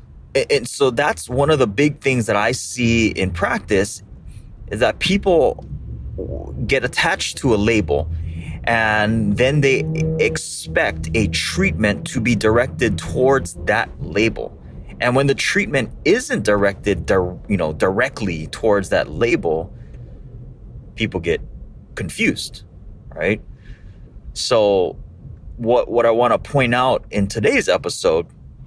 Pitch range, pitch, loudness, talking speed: 95-130 Hz, 110 Hz, -18 LUFS, 125 wpm